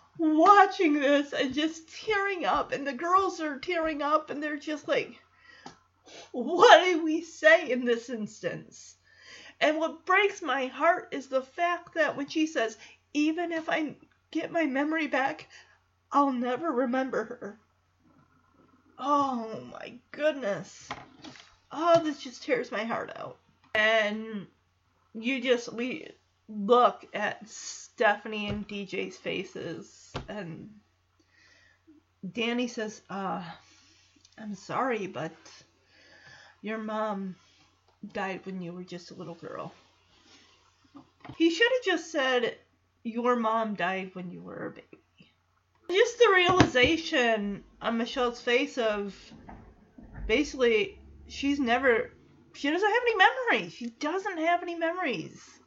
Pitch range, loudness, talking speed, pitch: 220-325 Hz, -27 LUFS, 125 wpm, 265 Hz